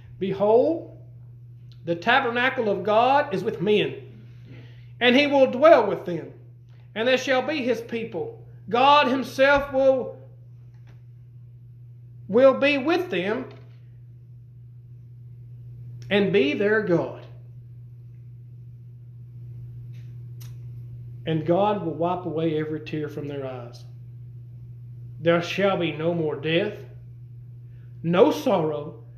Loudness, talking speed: -22 LUFS, 100 wpm